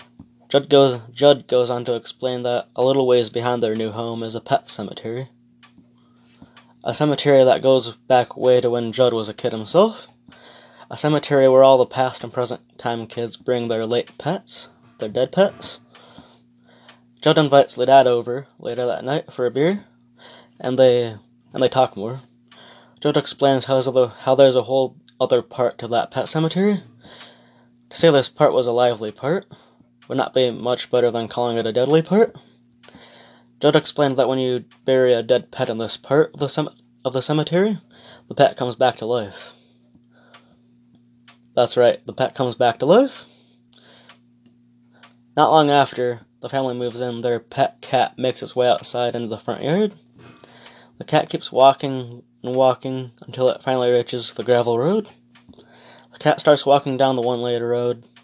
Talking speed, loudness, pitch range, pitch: 175 wpm, -19 LUFS, 120-135 Hz, 125 Hz